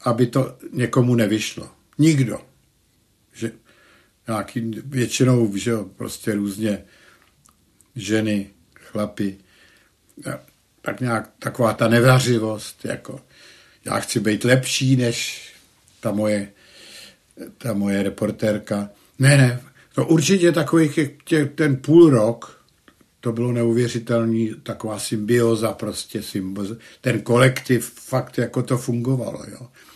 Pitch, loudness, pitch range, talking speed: 120 Hz, -21 LUFS, 110-130 Hz, 105 wpm